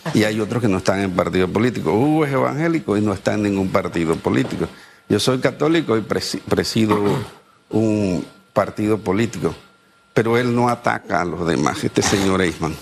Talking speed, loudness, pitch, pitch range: 180 wpm, -19 LUFS, 105 Hz, 95-120 Hz